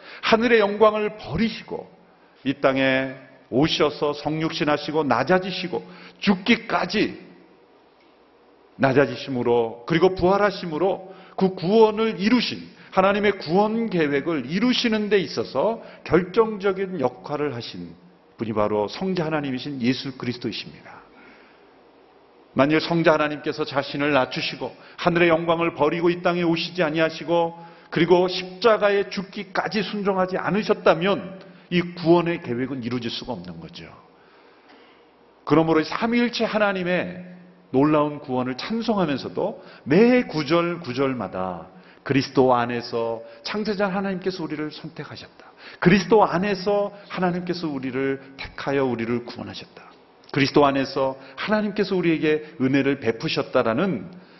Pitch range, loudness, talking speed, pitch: 135-195 Hz, -22 LUFS, 305 characters per minute, 165 Hz